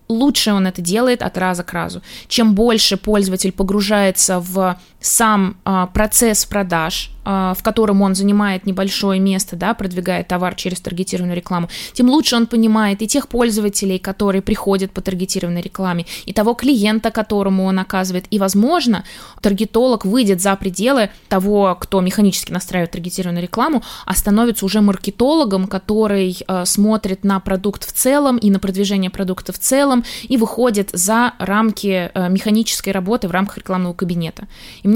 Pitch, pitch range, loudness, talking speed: 200 Hz, 185-220 Hz, -16 LUFS, 155 wpm